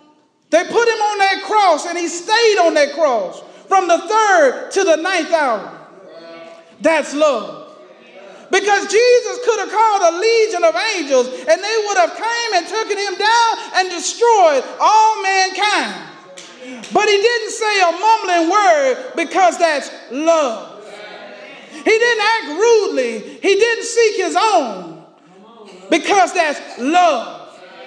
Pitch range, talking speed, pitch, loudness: 310-435 Hz, 140 wpm, 365 Hz, -15 LUFS